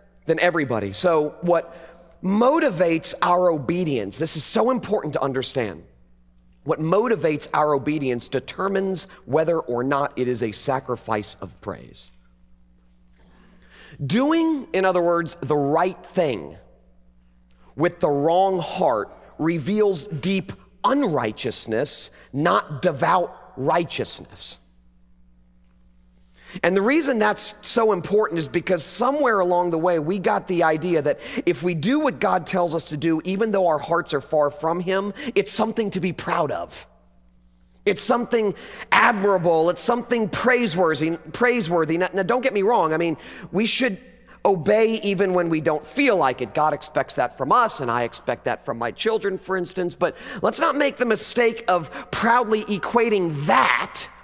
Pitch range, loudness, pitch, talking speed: 140-205 Hz, -21 LUFS, 170 Hz, 145 wpm